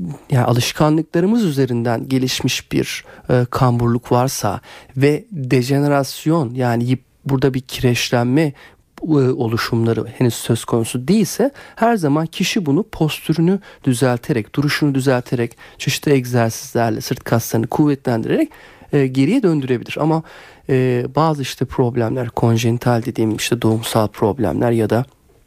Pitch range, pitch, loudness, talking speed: 120-150 Hz, 130 Hz, -18 LUFS, 115 wpm